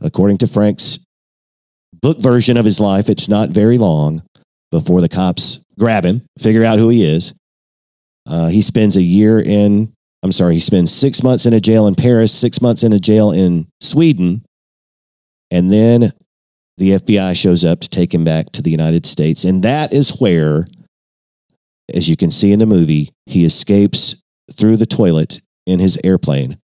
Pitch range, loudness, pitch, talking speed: 85-110 Hz, -11 LUFS, 95 Hz, 175 wpm